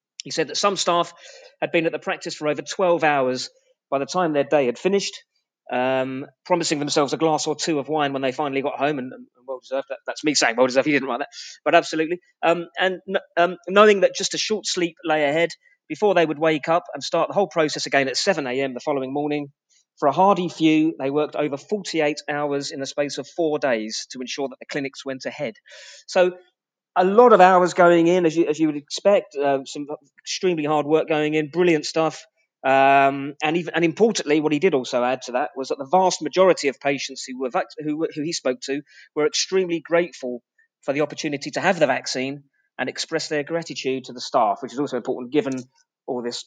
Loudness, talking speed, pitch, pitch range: -21 LUFS, 220 wpm, 150 Hz, 140-175 Hz